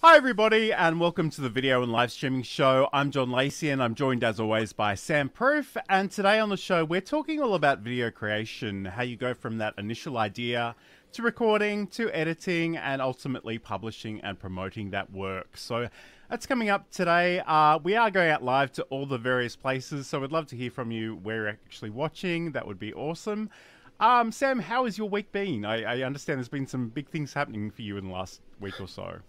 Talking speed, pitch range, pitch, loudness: 215 wpm, 110-180 Hz, 135 Hz, -27 LUFS